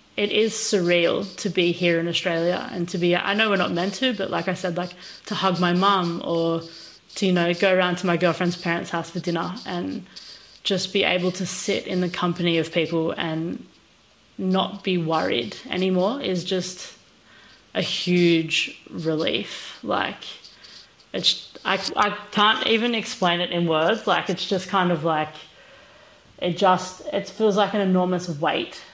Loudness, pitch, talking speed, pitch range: -23 LUFS, 180 Hz, 175 wpm, 175-200 Hz